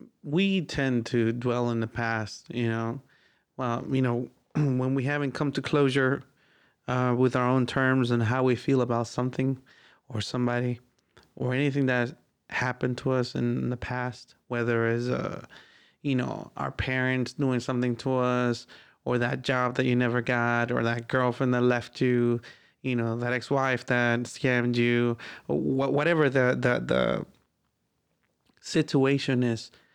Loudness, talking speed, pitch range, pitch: -27 LUFS, 160 wpm, 120-135 Hz, 125 Hz